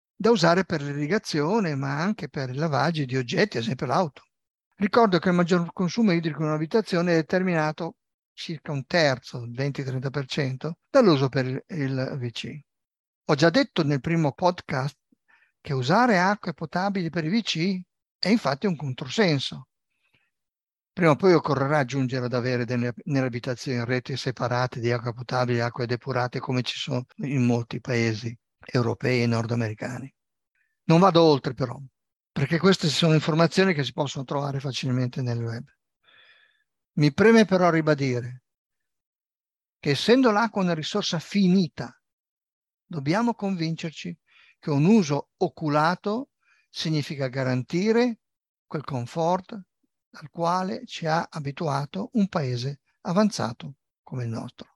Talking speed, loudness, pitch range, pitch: 135 wpm, -25 LUFS, 130-180 Hz, 155 Hz